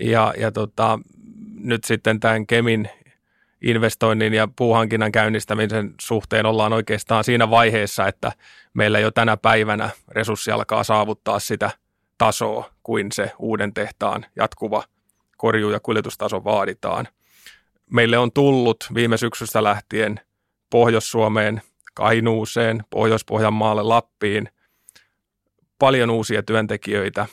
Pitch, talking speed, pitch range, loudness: 110 Hz, 105 wpm, 110-115 Hz, -20 LUFS